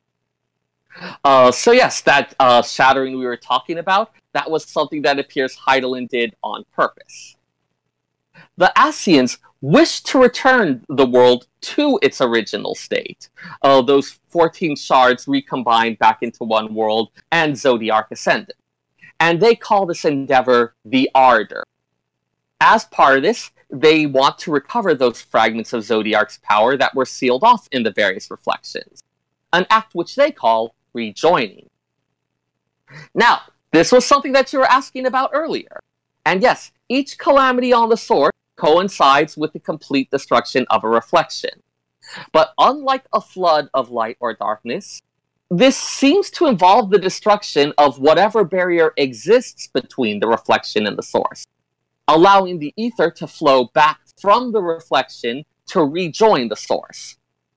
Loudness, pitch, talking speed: -16 LUFS, 145 Hz, 145 wpm